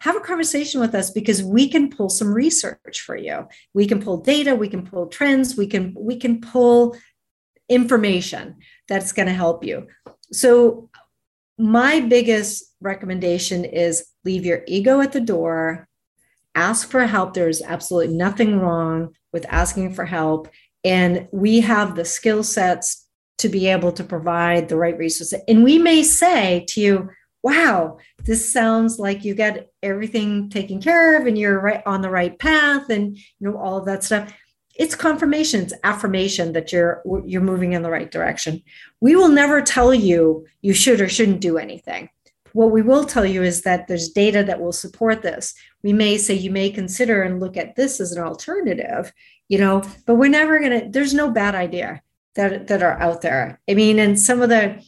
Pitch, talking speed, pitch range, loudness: 200 Hz, 185 wpm, 180-235 Hz, -18 LUFS